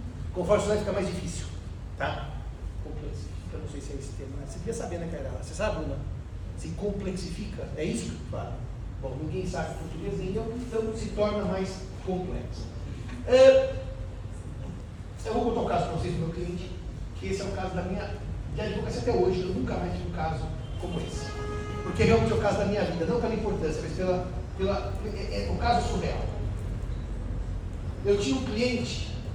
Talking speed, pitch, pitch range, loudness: 195 wpm, 100 Hz, 90-135 Hz, -30 LUFS